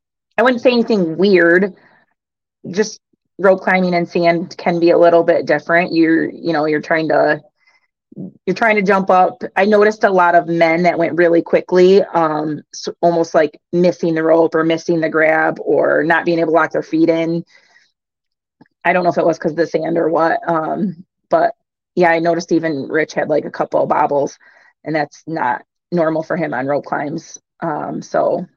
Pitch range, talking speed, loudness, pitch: 165-185 Hz, 195 wpm, -15 LUFS, 170 Hz